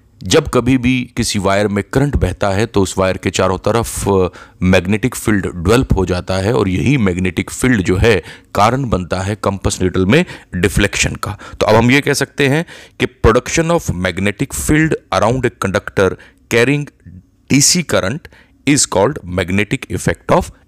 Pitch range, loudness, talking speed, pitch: 95-130 Hz, -15 LUFS, 170 wpm, 100 Hz